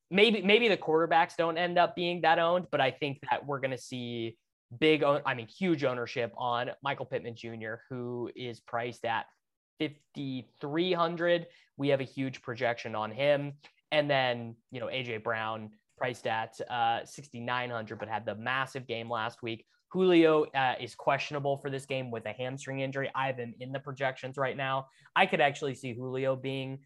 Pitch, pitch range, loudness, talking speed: 135 Hz, 120-150 Hz, -31 LUFS, 190 wpm